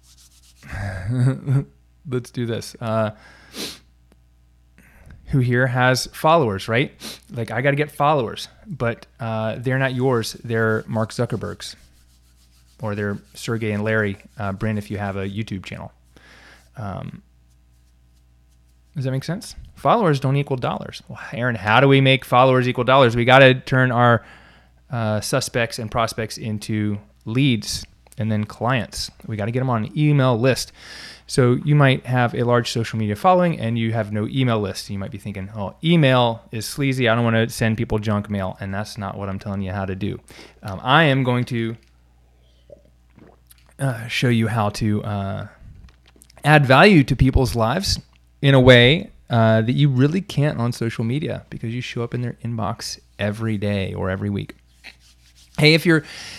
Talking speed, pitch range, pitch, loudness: 170 wpm, 95-130 Hz, 110 Hz, -20 LUFS